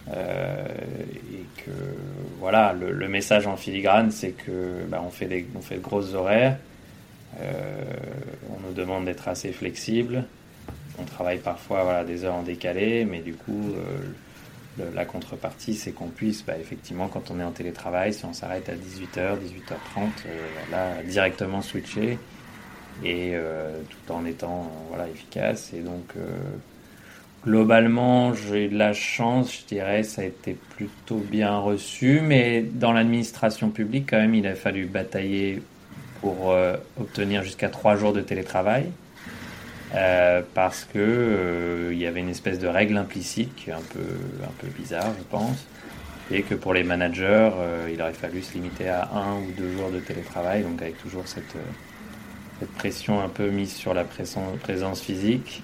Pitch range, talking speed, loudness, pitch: 90-105 Hz, 165 wpm, -26 LUFS, 95 Hz